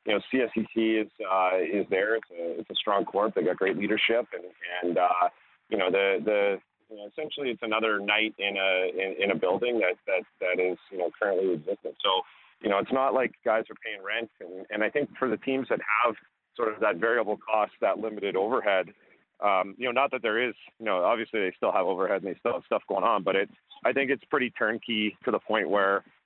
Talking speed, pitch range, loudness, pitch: 245 wpm, 100-140 Hz, -27 LUFS, 110 Hz